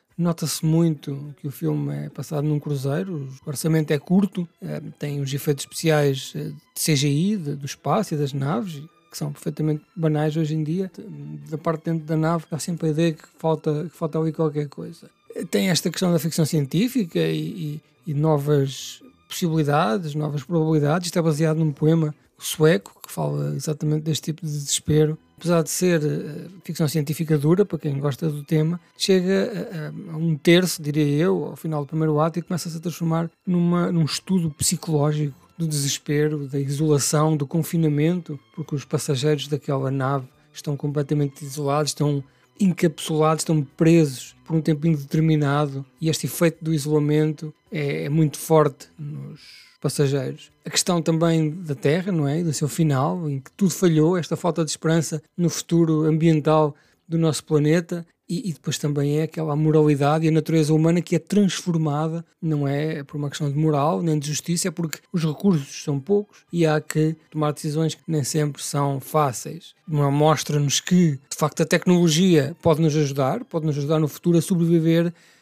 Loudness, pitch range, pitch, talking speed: -22 LUFS, 150-165 Hz, 155 Hz, 175 wpm